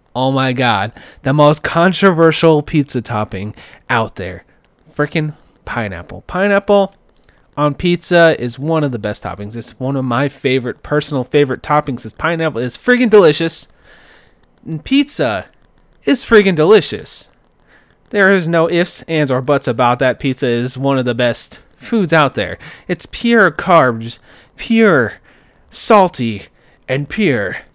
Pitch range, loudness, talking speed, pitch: 125-175 Hz, -14 LUFS, 135 wpm, 150 Hz